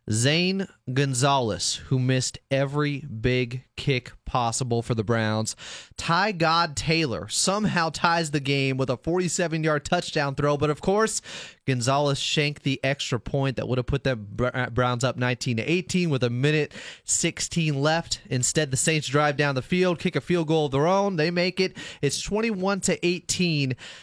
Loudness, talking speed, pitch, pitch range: -24 LUFS, 165 wpm, 145 Hz, 125-170 Hz